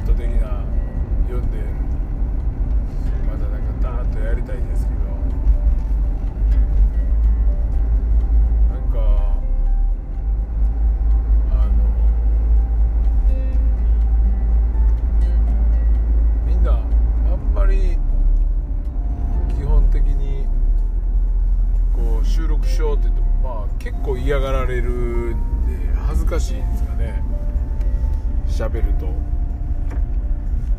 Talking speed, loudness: 140 characters per minute, -21 LUFS